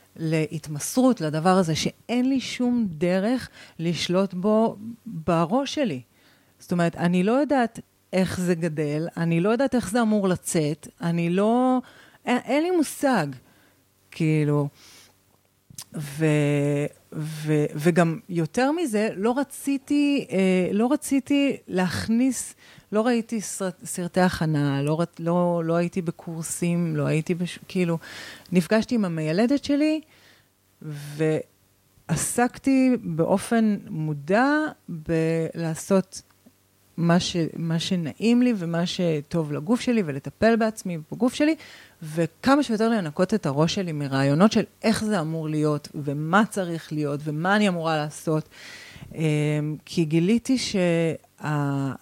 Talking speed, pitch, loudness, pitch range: 115 wpm, 175 Hz, -24 LUFS, 155-225 Hz